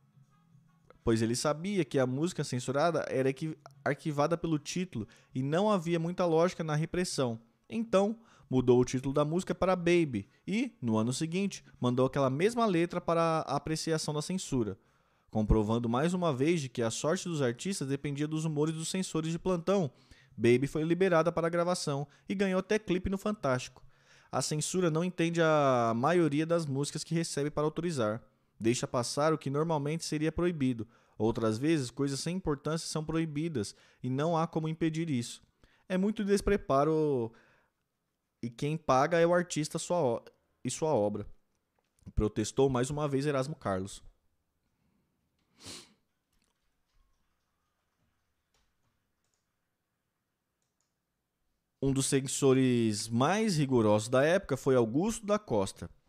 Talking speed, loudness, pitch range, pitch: 140 wpm, -31 LUFS, 125-170 Hz, 150 Hz